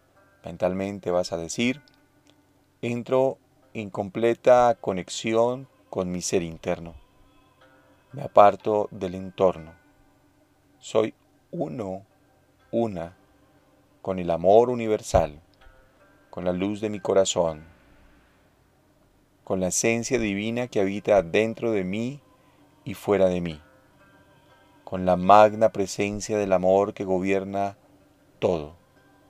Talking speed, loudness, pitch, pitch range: 105 wpm, -24 LUFS, 100 Hz, 95-115 Hz